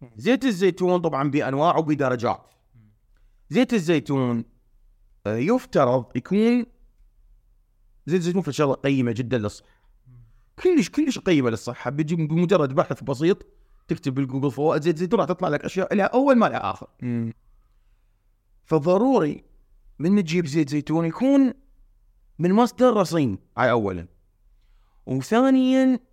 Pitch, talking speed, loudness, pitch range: 140 Hz, 115 wpm, -22 LUFS, 110-185 Hz